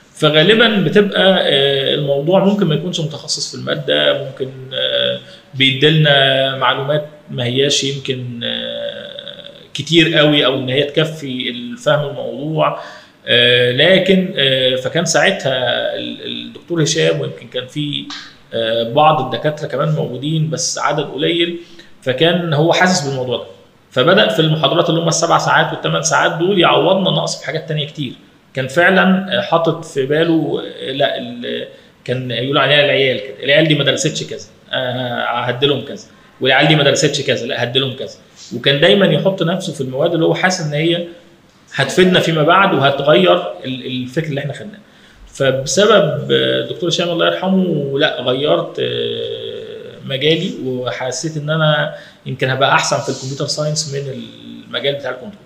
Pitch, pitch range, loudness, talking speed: 150 Hz, 130-170 Hz, -15 LUFS, 135 wpm